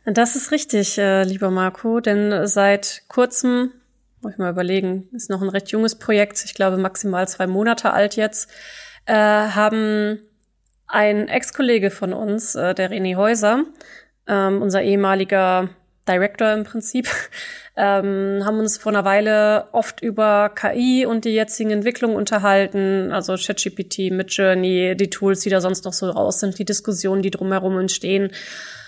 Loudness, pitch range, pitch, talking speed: -19 LUFS, 195-220 Hz, 205 Hz, 140 wpm